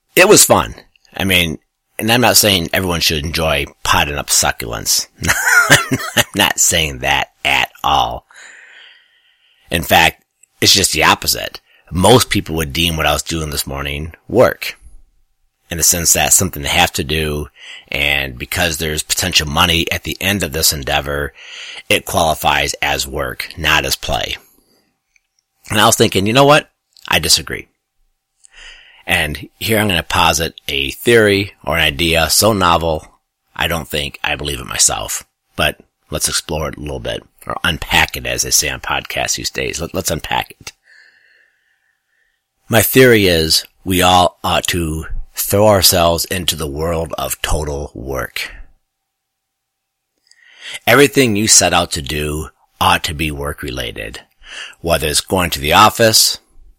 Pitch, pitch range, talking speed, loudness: 85 Hz, 75-105 Hz, 155 wpm, -14 LUFS